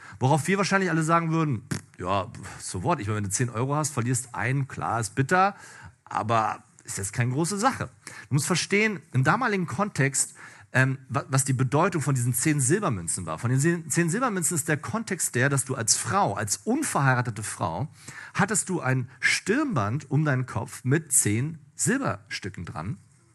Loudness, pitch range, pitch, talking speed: -25 LUFS, 125-170 Hz, 140 Hz, 180 wpm